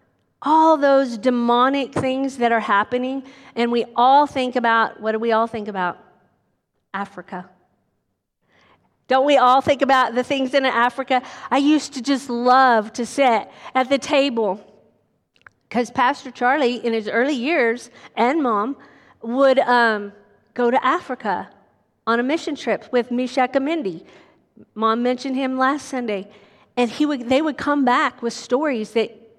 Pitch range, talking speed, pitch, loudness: 230-270 Hz, 150 wpm, 250 Hz, -19 LUFS